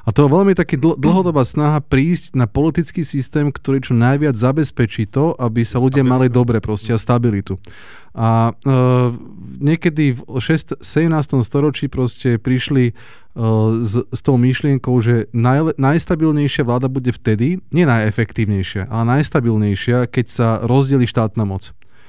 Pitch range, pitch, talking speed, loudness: 115-150 Hz, 125 Hz, 145 wpm, -16 LUFS